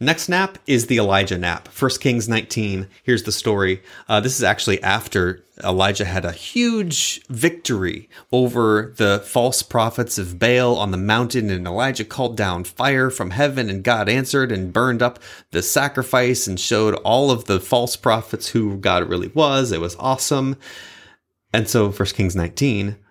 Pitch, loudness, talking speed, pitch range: 110 Hz, -19 LUFS, 170 wpm, 95-130 Hz